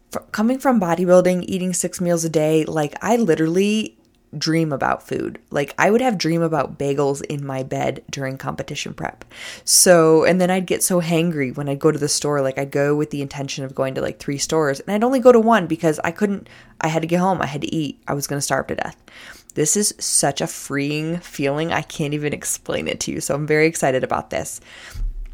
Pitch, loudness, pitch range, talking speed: 160 Hz, -19 LUFS, 140-180 Hz, 225 wpm